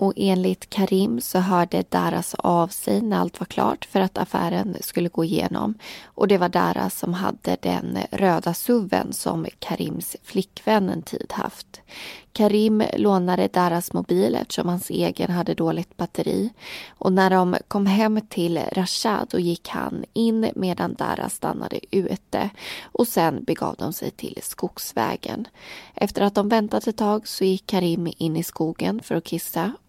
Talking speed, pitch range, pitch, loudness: 160 wpm, 170-205 Hz, 185 Hz, -23 LUFS